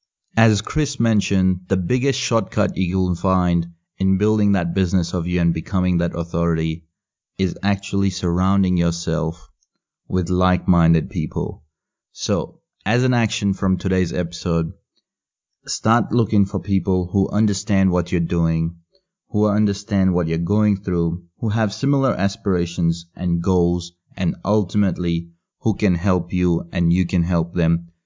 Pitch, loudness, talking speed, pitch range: 95 Hz, -20 LUFS, 140 wpm, 85-105 Hz